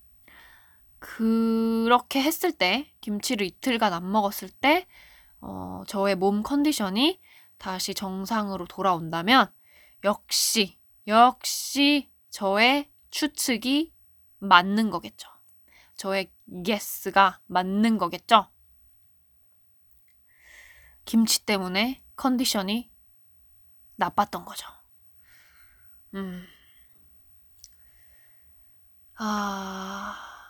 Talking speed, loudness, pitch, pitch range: 150 characters per minute, -24 LUFS, 210 Hz, 190-255 Hz